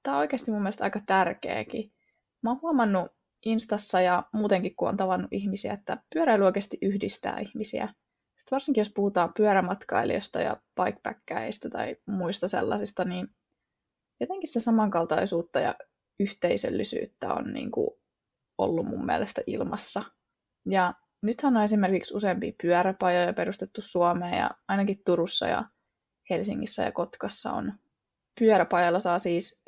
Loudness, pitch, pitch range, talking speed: -28 LUFS, 195 Hz, 180-220 Hz, 130 wpm